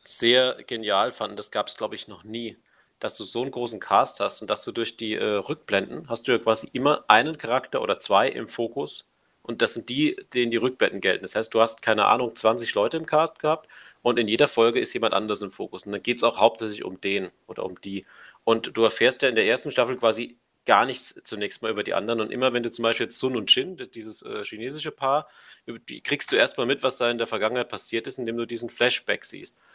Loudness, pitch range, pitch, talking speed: -24 LUFS, 115-125 Hz, 115 Hz, 240 wpm